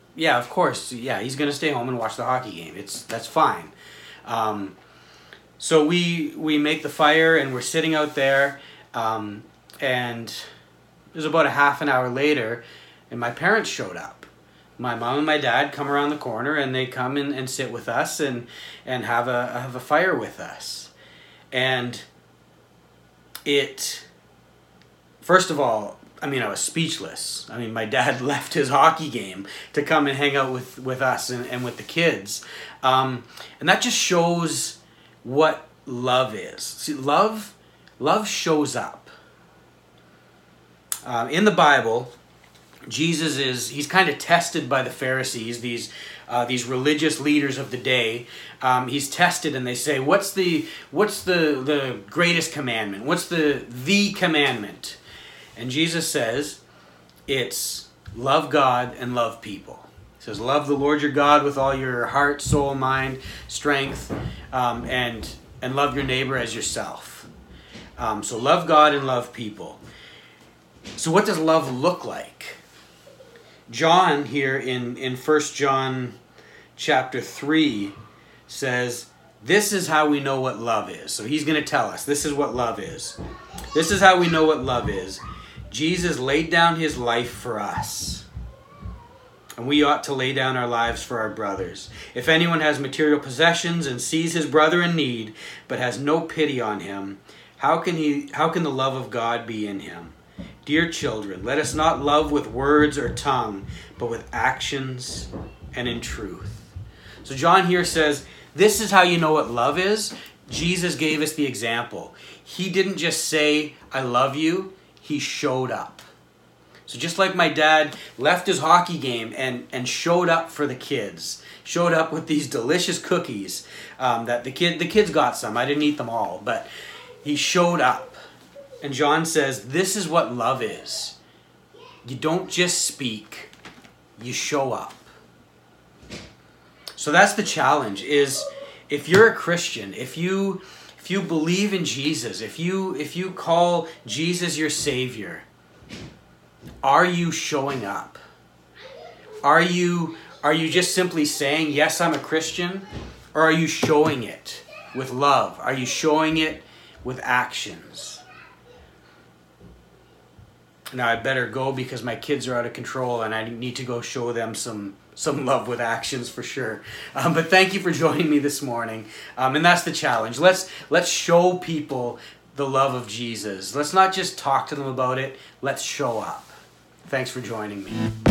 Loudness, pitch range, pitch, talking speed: -22 LUFS, 120-160 Hz, 140 Hz, 165 wpm